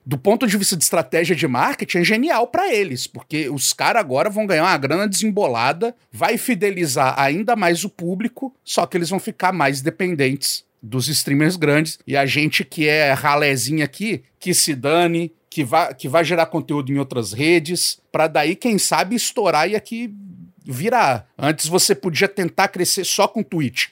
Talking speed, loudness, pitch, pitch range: 180 wpm, -18 LUFS, 175 Hz, 150-200 Hz